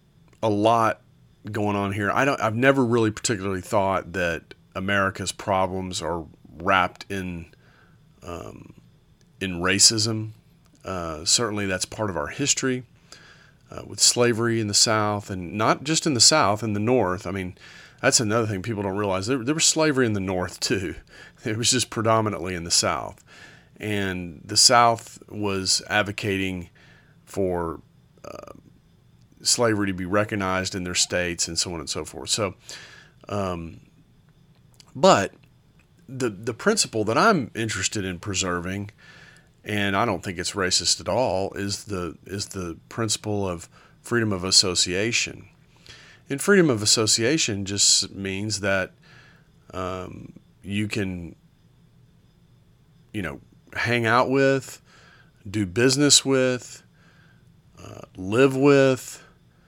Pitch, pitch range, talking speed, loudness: 105 Hz, 95-125 Hz, 135 wpm, -22 LUFS